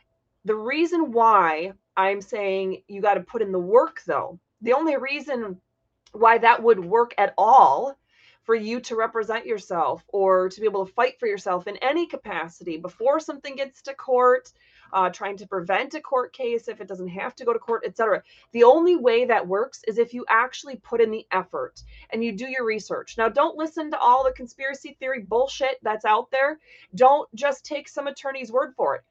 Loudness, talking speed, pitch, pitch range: -23 LUFS, 200 wpm, 235 Hz, 200-275 Hz